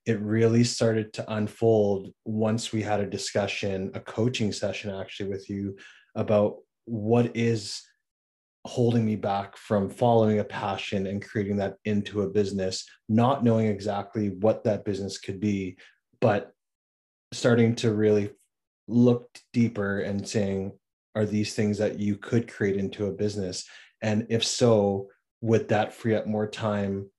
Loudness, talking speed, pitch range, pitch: -27 LUFS, 150 wpm, 100-115 Hz, 105 Hz